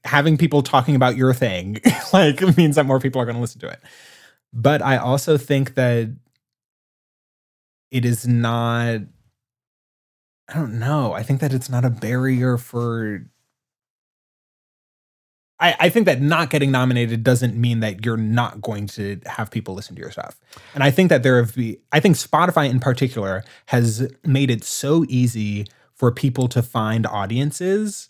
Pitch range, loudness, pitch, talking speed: 115-140 Hz, -19 LUFS, 125 Hz, 165 wpm